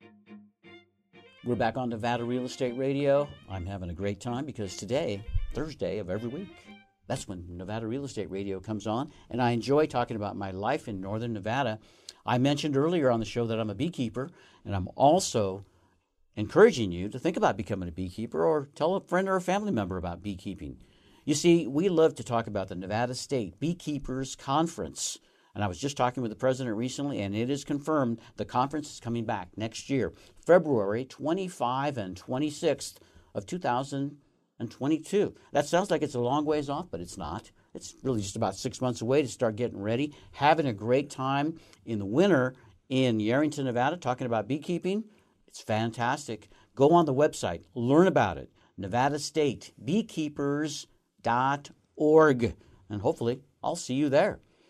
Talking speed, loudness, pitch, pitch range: 170 wpm, -29 LUFS, 125 Hz, 105-150 Hz